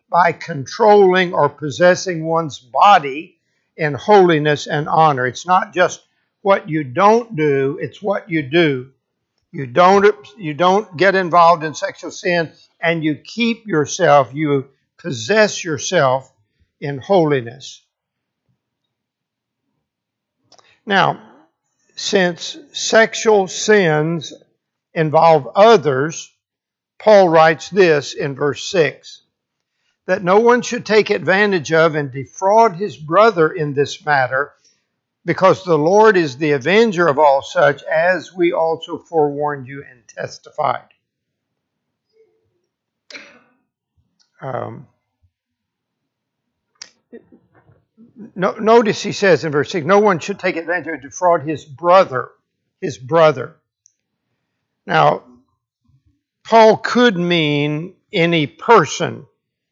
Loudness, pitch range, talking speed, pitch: -15 LUFS, 145-195 Hz, 110 wpm, 165 Hz